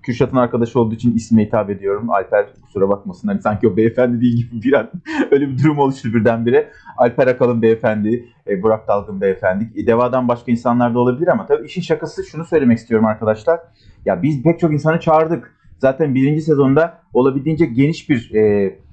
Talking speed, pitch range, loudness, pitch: 175 wpm, 115-155 Hz, -16 LUFS, 125 Hz